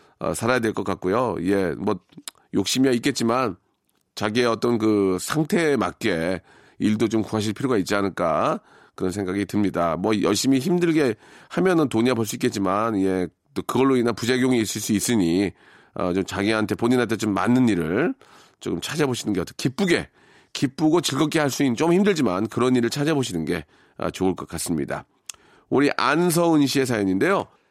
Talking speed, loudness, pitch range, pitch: 350 characters per minute, -22 LUFS, 100-135 Hz, 115 Hz